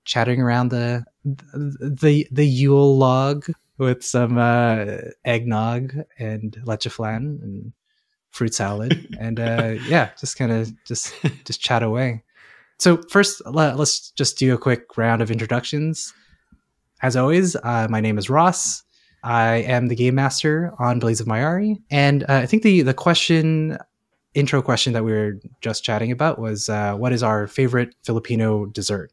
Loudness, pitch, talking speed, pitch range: -20 LUFS, 125 Hz, 160 wpm, 115-145 Hz